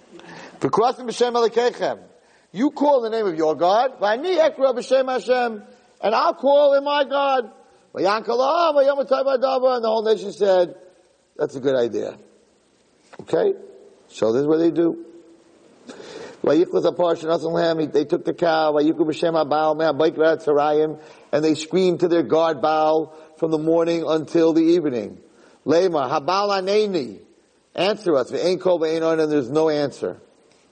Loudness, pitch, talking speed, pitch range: -20 LUFS, 180 Hz, 170 wpm, 160-260 Hz